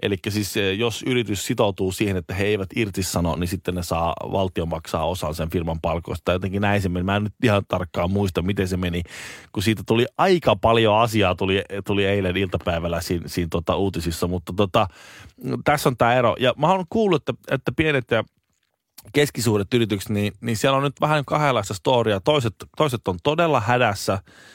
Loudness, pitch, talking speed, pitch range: -22 LUFS, 100 Hz, 190 wpm, 90-115 Hz